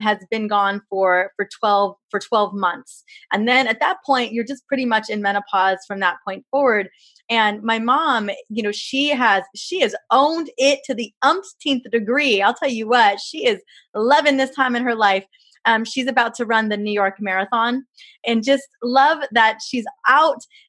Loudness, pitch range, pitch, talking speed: -19 LUFS, 205-275 Hz, 235 Hz, 190 wpm